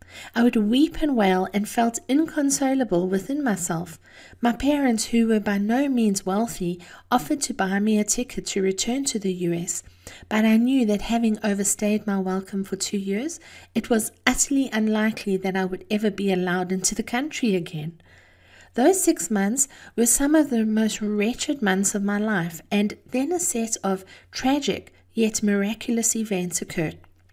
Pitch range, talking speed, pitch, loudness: 190-240 Hz, 170 wpm, 215 Hz, -23 LUFS